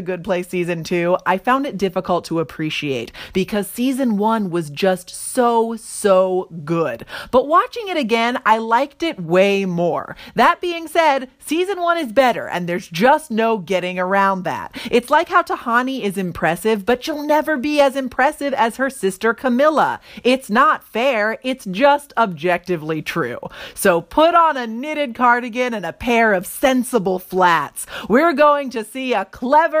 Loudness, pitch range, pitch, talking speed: -18 LUFS, 185-280 Hz, 230 Hz, 165 wpm